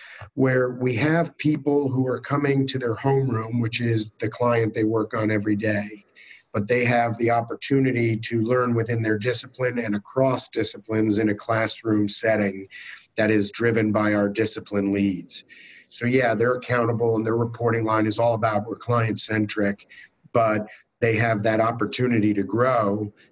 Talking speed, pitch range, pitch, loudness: 165 wpm, 105-125 Hz, 115 Hz, -23 LUFS